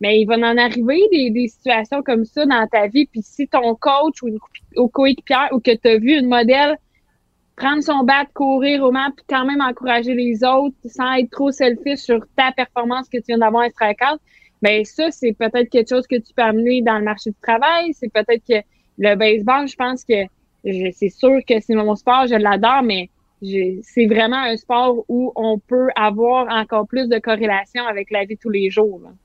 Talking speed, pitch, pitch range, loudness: 215 wpm, 240 Hz, 220-265 Hz, -17 LUFS